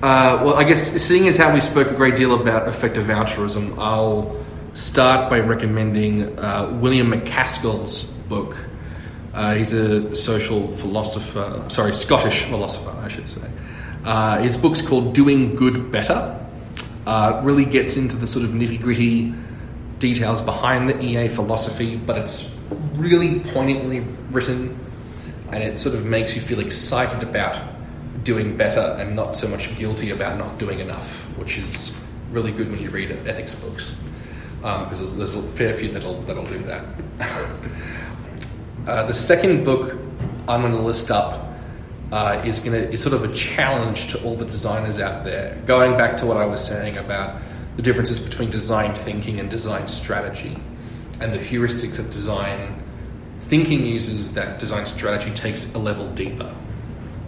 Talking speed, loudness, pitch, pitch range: 160 wpm, -20 LUFS, 115 Hz, 105-125 Hz